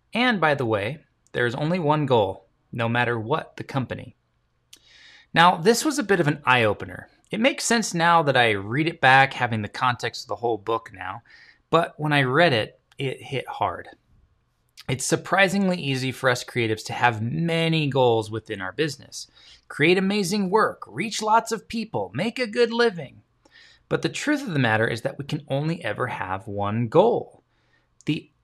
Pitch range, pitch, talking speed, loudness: 115-175 Hz, 140 Hz, 185 wpm, -23 LUFS